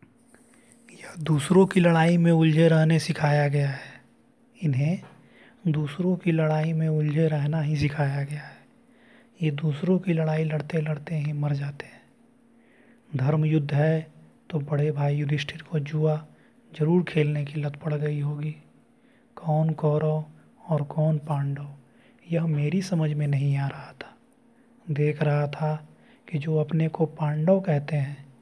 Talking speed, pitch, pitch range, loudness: 145 wpm, 155 Hz, 150-170 Hz, -25 LUFS